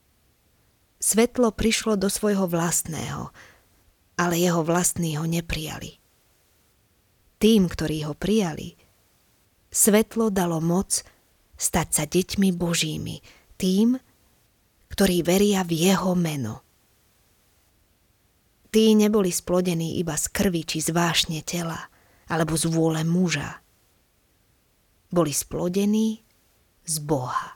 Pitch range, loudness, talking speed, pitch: 150-195 Hz, -23 LUFS, 100 wpm, 170 Hz